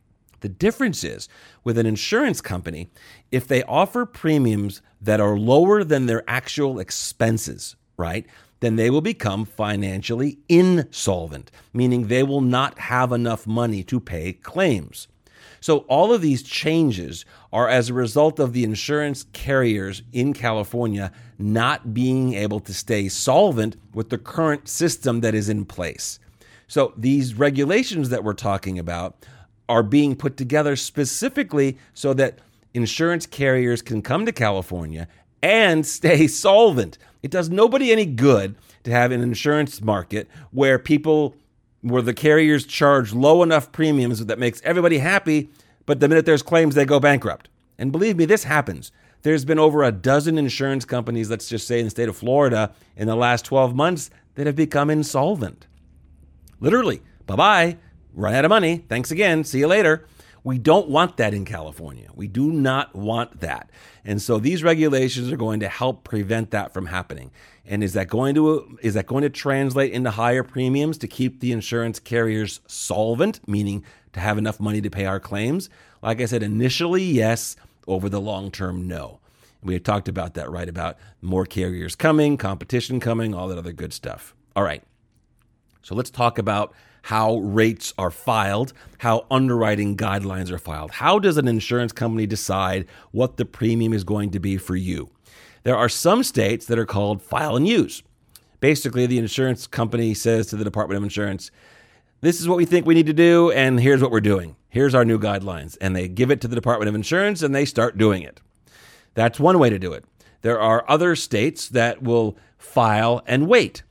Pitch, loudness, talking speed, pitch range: 120 Hz, -20 LUFS, 175 wpm, 105-140 Hz